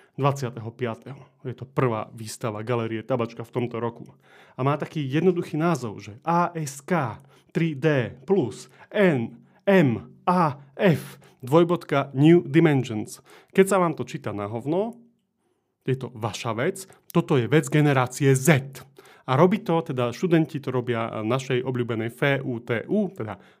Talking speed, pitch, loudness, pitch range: 125 wpm, 135 Hz, -24 LUFS, 120-165 Hz